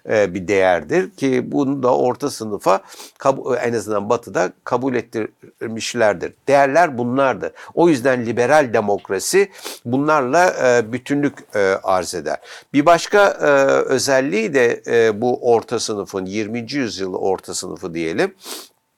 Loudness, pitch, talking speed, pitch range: -18 LUFS, 130 Hz, 110 wpm, 120-165 Hz